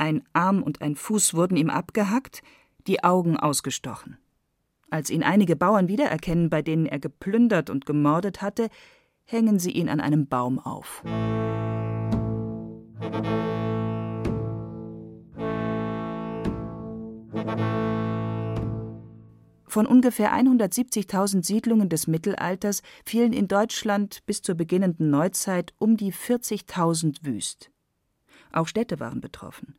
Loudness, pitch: -25 LUFS, 160 Hz